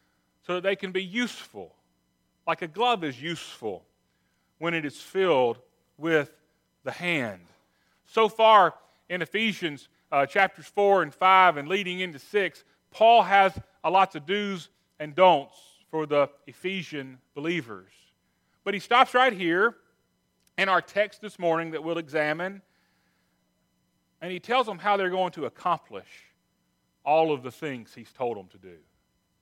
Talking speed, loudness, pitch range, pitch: 150 wpm, -25 LUFS, 145-195 Hz, 170 Hz